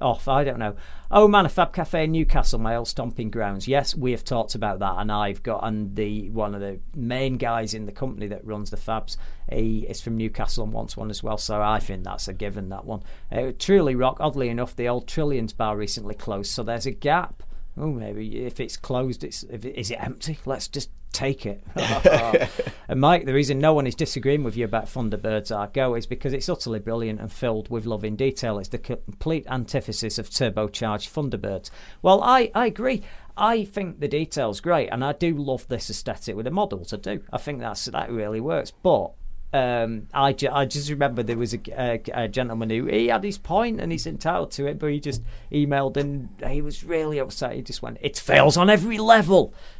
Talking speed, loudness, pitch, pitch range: 220 wpm, -24 LUFS, 120 Hz, 110-145 Hz